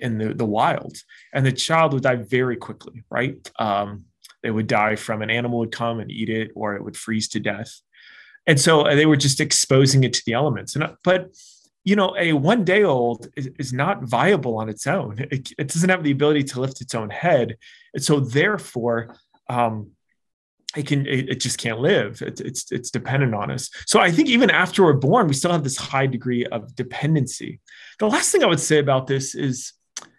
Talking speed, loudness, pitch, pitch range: 215 wpm, -20 LUFS, 135 Hz, 115-150 Hz